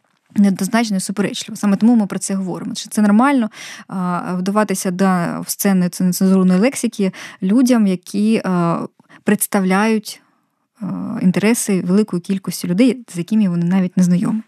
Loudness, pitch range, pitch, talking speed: -17 LUFS, 185-220 Hz, 200 Hz, 125 wpm